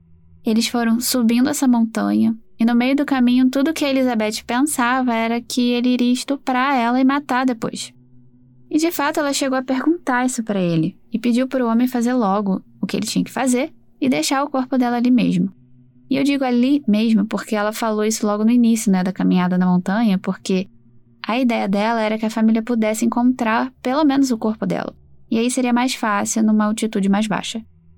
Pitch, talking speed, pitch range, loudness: 235 Hz, 205 wpm, 205-255 Hz, -19 LUFS